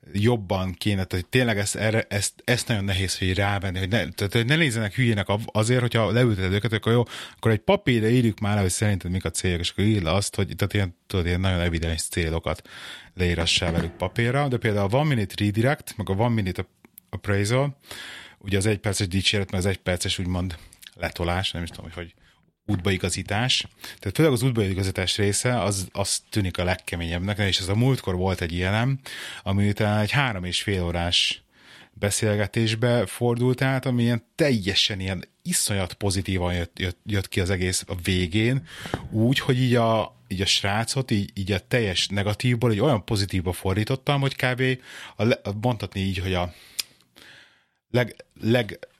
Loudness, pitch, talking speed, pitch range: -24 LUFS, 100 Hz, 175 wpm, 95-115 Hz